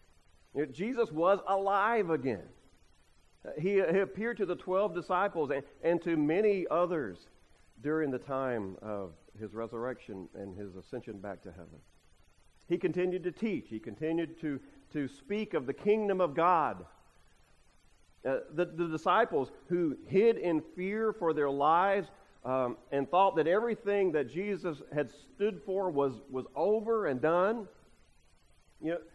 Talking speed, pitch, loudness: 145 wpm, 150 Hz, -32 LUFS